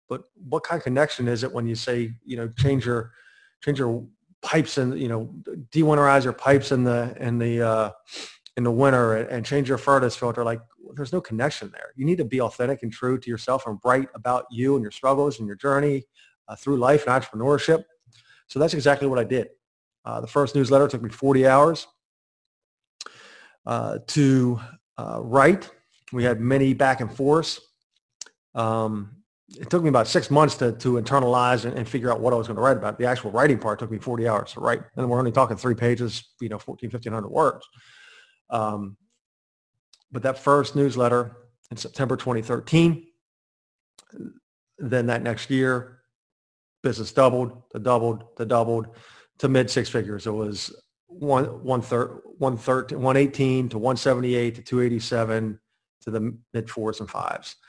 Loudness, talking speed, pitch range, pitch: -23 LUFS, 175 wpm, 115-140 Hz, 125 Hz